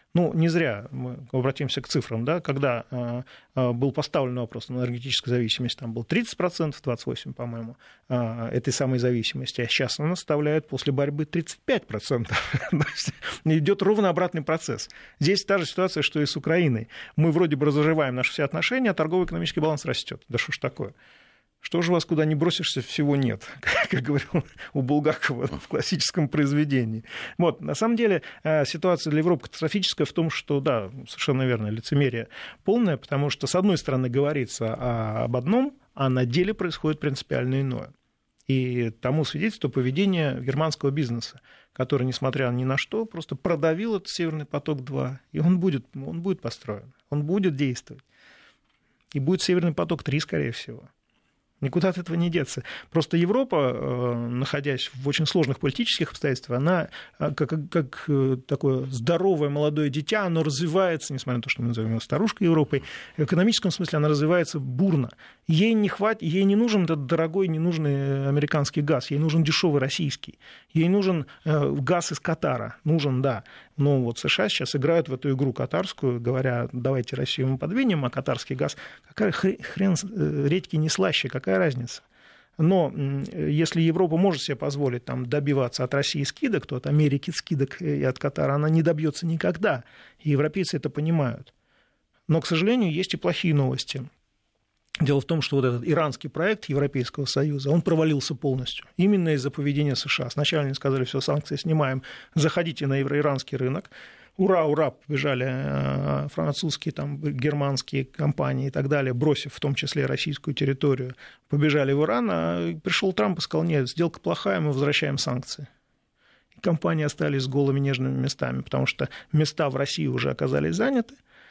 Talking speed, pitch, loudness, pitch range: 160 wpm, 145 Hz, -25 LUFS, 130-165 Hz